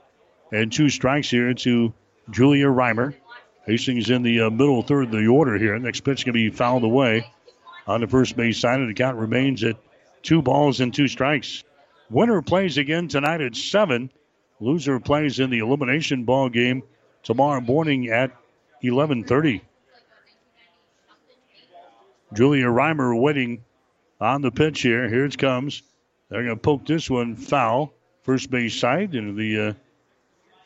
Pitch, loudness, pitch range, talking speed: 130 Hz, -21 LUFS, 120-145 Hz, 160 wpm